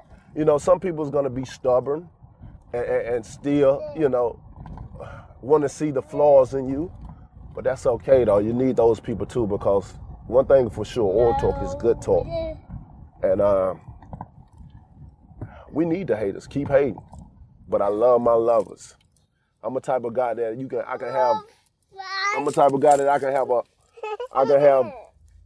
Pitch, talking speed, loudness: 145 Hz, 175 wpm, -22 LUFS